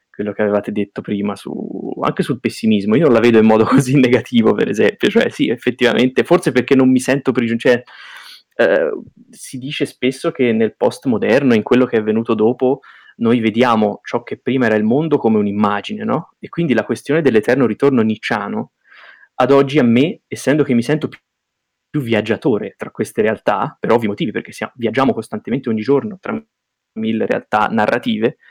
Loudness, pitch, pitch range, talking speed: -16 LUFS, 125 Hz, 110-140 Hz, 180 wpm